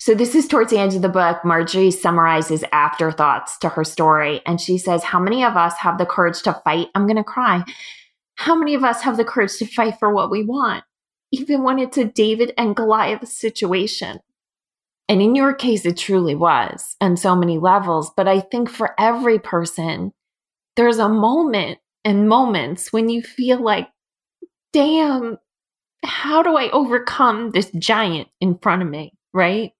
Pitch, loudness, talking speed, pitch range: 210 Hz, -18 LUFS, 180 wpm, 175-240 Hz